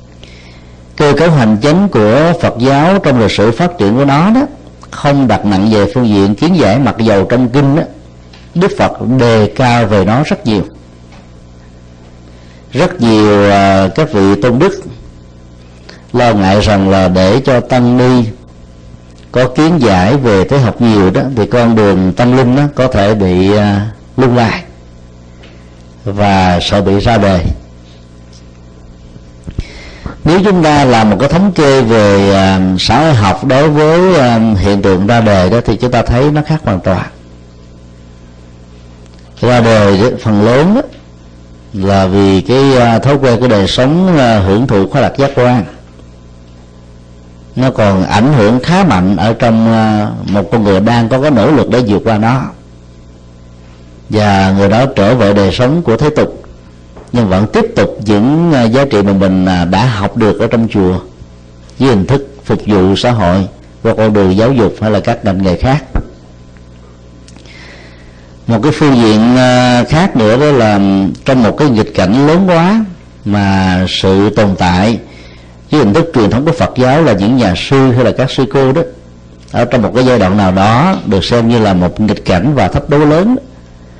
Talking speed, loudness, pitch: 175 wpm, -9 LUFS, 100 Hz